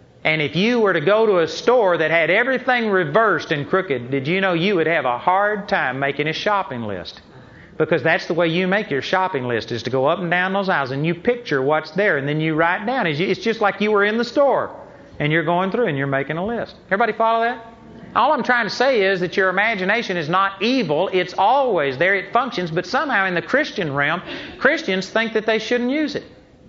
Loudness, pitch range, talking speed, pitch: -19 LUFS, 165-225 Hz, 235 wpm, 190 Hz